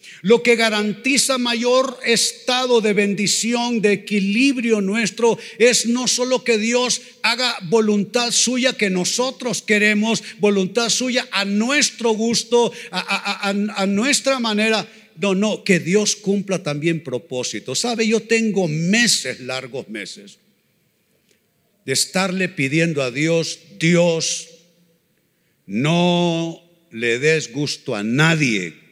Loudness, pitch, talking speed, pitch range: -18 LUFS, 205 Hz, 120 wpm, 170-235 Hz